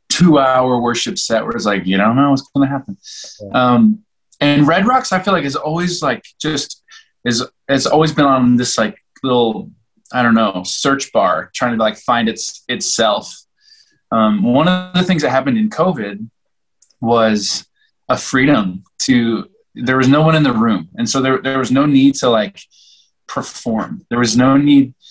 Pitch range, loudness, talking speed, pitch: 120-180 Hz, -15 LUFS, 185 wpm, 135 Hz